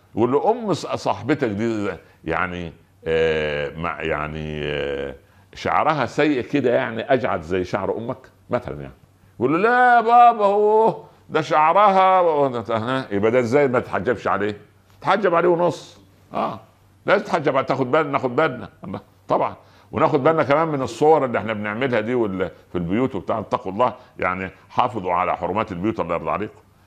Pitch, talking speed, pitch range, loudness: 120 Hz, 140 wpm, 95-155 Hz, -20 LUFS